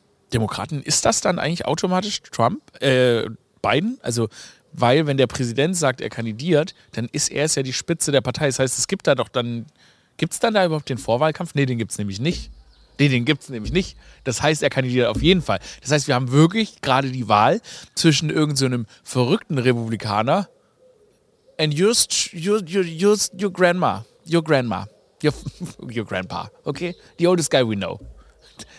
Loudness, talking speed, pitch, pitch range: -21 LUFS, 185 wpm, 145 Hz, 125-175 Hz